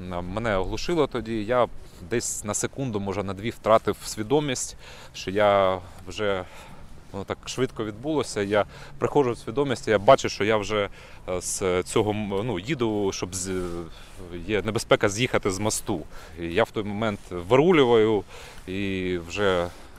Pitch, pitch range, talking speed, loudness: 105 Hz, 90-115 Hz, 140 wpm, -25 LUFS